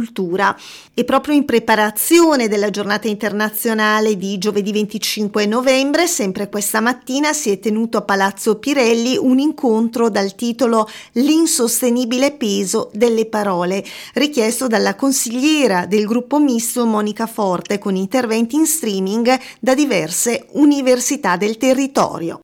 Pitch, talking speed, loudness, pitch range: 225 Hz, 120 wpm, -16 LUFS, 210-260 Hz